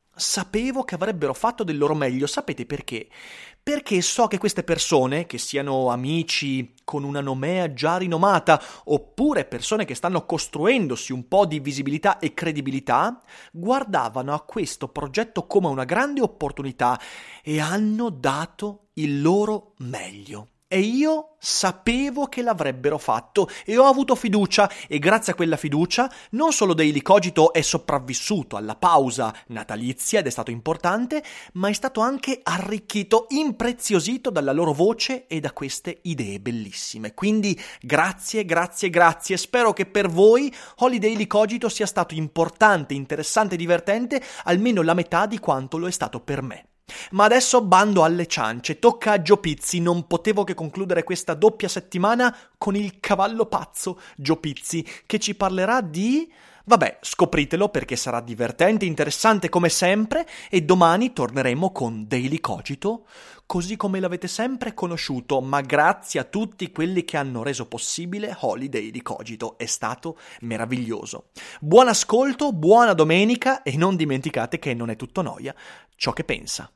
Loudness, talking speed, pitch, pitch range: -22 LUFS, 145 wpm, 175 Hz, 145-215 Hz